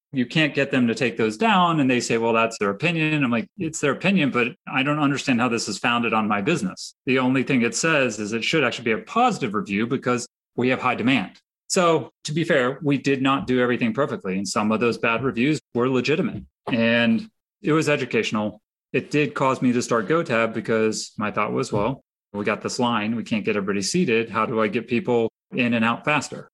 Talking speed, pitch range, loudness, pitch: 230 wpm, 115-150 Hz, -22 LUFS, 125 Hz